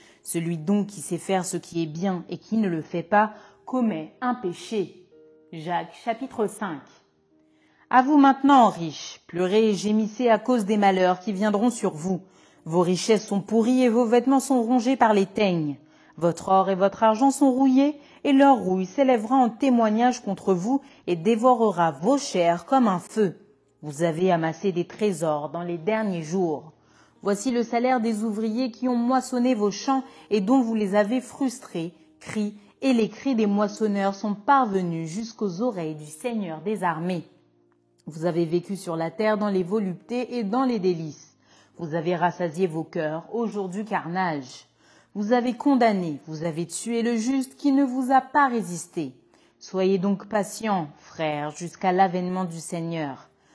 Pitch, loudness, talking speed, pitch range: 200 Hz, -24 LUFS, 170 wpm, 170-235 Hz